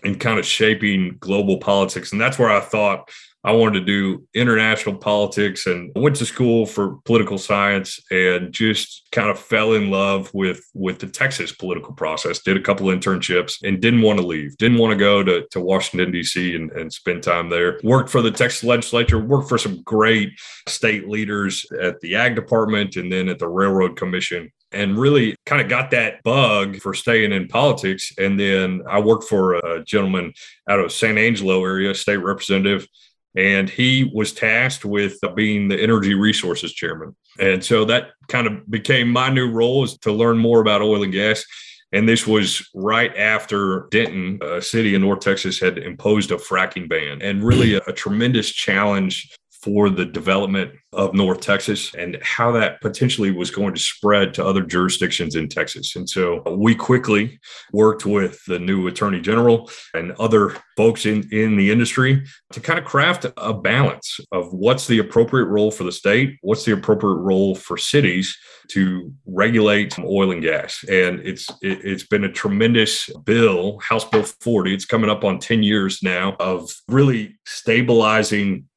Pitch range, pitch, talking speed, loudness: 95-115 Hz, 100 Hz, 180 wpm, -18 LUFS